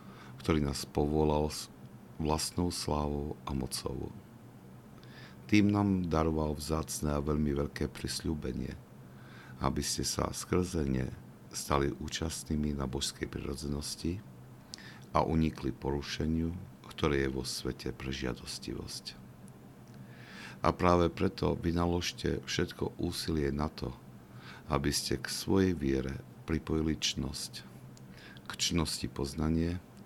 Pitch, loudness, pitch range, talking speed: 70 Hz, -33 LUFS, 65-80 Hz, 105 wpm